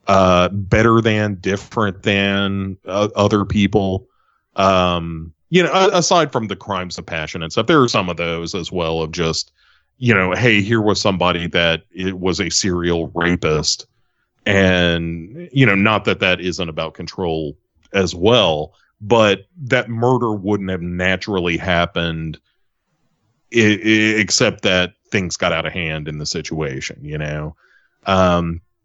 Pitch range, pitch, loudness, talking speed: 85-105 Hz, 95 Hz, -17 LUFS, 155 wpm